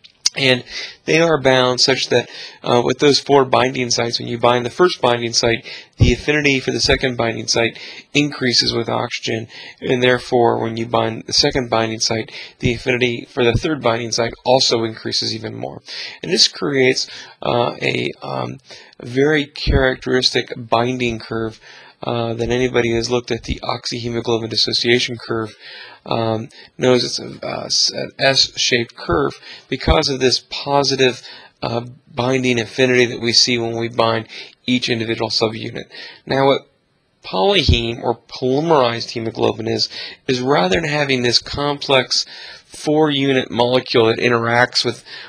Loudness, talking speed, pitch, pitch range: -17 LUFS, 150 wpm, 120 Hz, 115-130 Hz